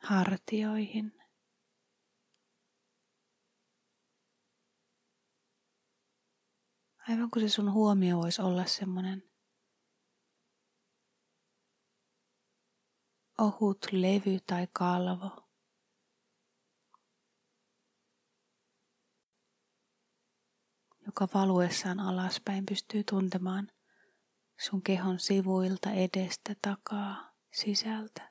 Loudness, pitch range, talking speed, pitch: -32 LUFS, 185-210 Hz, 50 wpm, 195 Hz